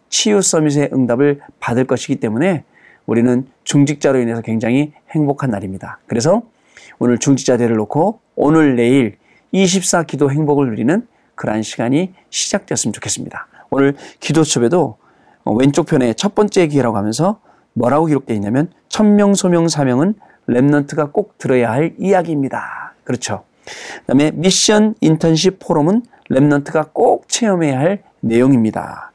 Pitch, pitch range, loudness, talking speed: 145 Hz, 125-175 Hz, -15 LUFS, 330 characters per minute